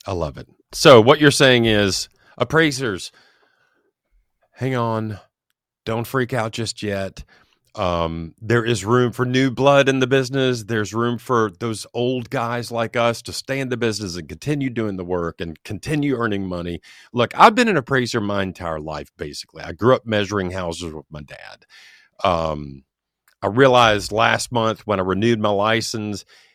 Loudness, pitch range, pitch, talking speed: -19 LUFS, 95-130 Hz, 115 Hz, 170 wpm